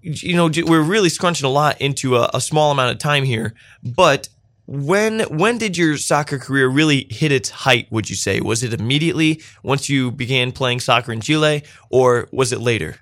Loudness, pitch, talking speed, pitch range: -17 LUFS, 135 Hz, 200 wpm, 120-155 Hz